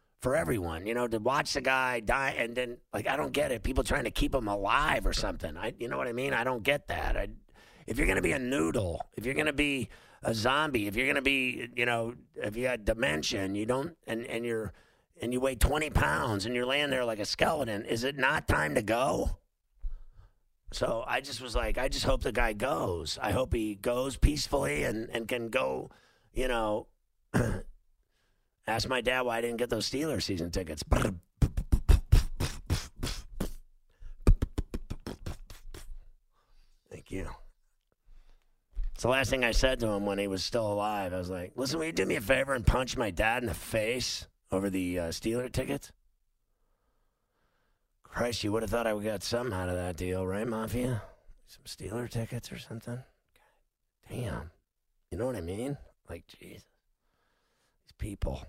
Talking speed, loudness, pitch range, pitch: 185 wpm, -31 LUFS, 95-125 Hz, 115 Hz